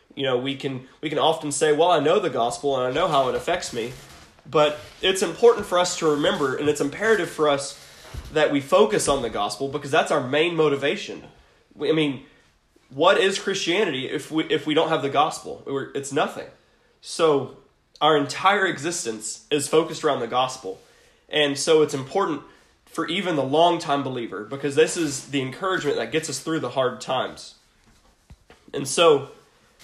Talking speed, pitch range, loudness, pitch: 185 wpm, 140-165 Hz, -22 LUFS, 150 Hz